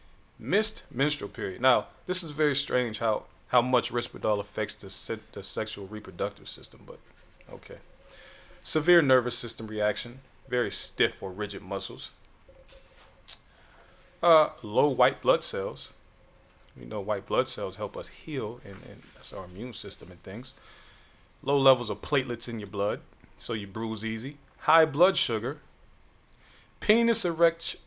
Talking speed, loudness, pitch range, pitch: 145 wpm, -28 LUFS, 105-140 Hz, 120 Hz